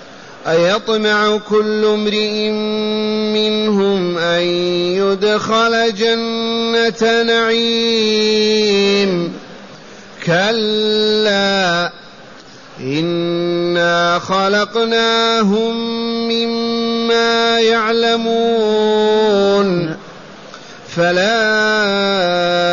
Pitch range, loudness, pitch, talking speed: 190-230 Hz, -14 LUFS, 215 Hz, 35 wpm